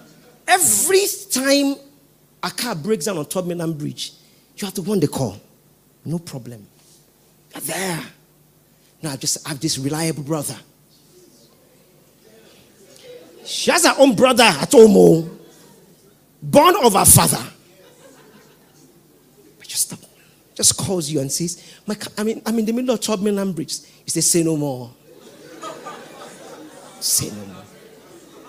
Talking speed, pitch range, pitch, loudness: 135 wpm, 155-225 Hz, 175 Hz, -17 LUFS